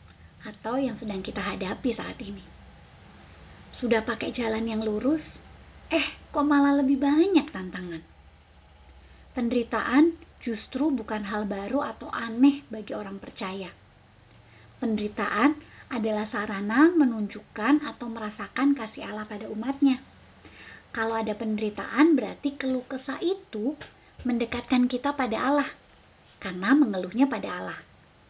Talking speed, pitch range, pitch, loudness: 110 wpm, 205-275 Hz, 230 Hz, -27 LUFS